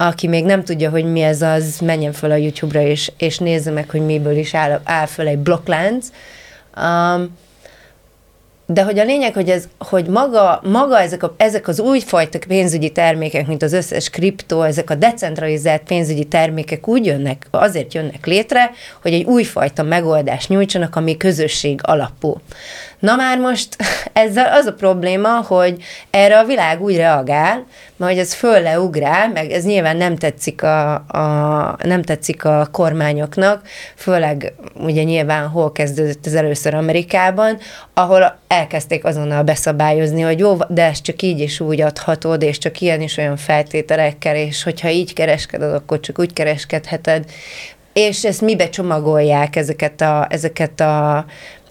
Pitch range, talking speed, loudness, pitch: 155-185 Hz, 155 wpm, -15 LUFS, 165 Hz